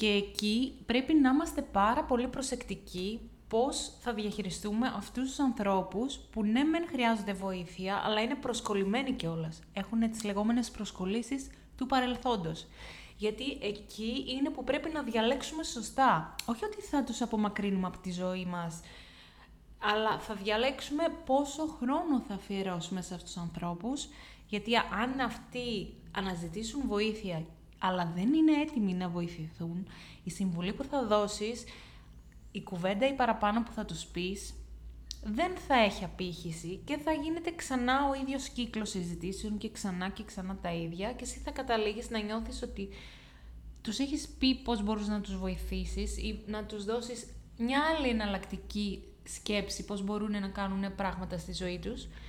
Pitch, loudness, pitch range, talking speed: 215 Hz, -33 LUFS, 190-250 Hz, 150 wpm